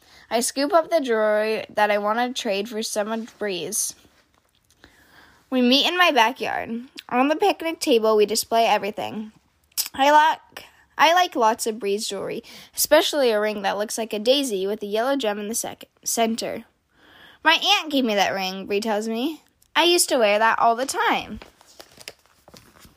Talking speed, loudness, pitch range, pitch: 175 wpm, -21 LUFS, 210-280 Hz, 225 Hz